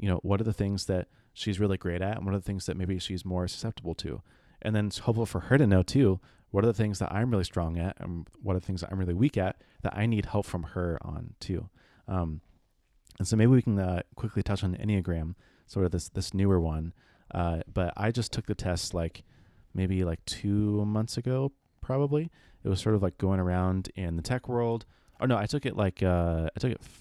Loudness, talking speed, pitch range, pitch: -30 LUFS, 245 wpm, 90-110 Hz, 95 Hz